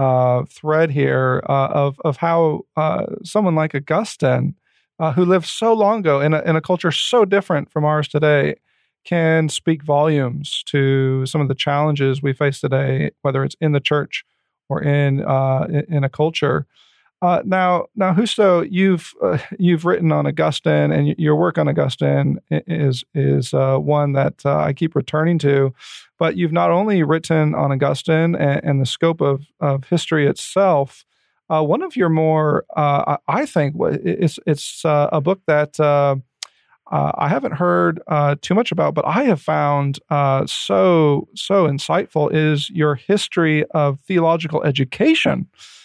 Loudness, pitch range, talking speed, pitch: -18 LUFS, 140-170 Hz, 170 wpm, 150 Hz